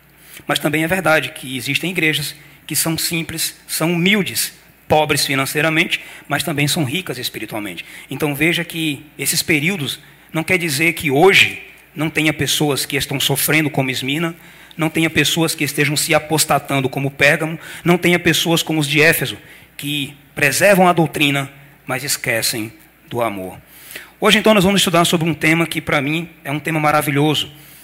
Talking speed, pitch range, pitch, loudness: 165 wpm, 145-165 Hz, 155 Hz, -16 LUFS